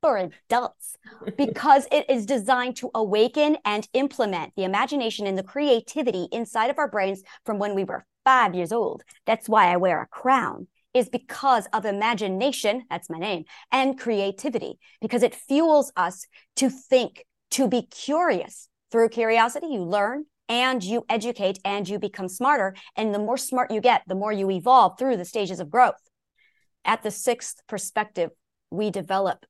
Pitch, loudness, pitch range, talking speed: 230 Hz, -24 LUFS, 200-260 Hz, 165 wpm